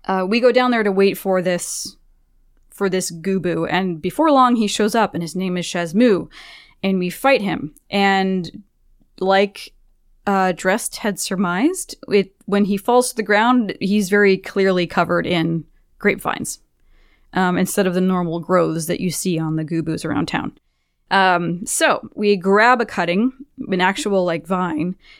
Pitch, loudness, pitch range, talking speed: 190 Hz, -19 LUFS, 175-210 Hz, 165 wpm